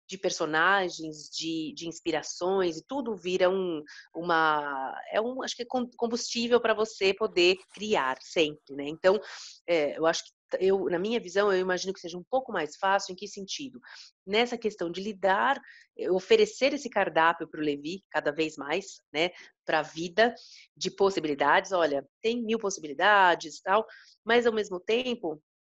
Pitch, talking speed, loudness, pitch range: 190 Hz, 165 wpm, -28 LUFS, 160-220 Hz